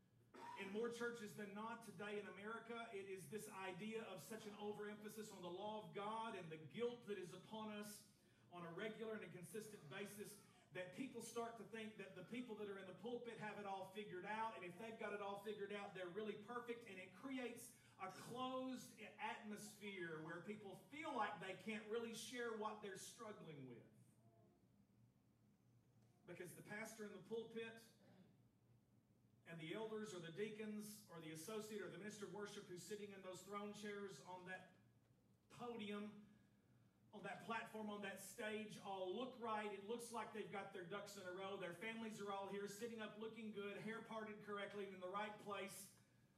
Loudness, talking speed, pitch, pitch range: -53 LUFS, 190 wpm, 210 Hz, 190-220 Hz